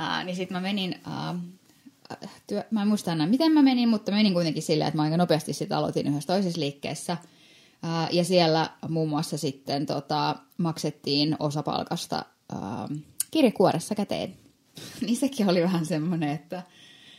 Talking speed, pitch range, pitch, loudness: 160 wpm, 155-195 Hz, 175 Hz, -26 LUFS